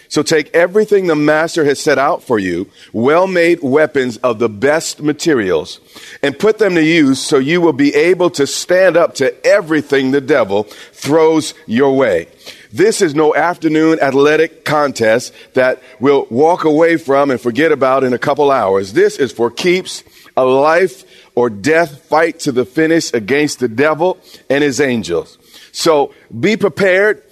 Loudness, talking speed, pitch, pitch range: -13 LUFS, 165 wpm, 155 Hz, 135-175 Hz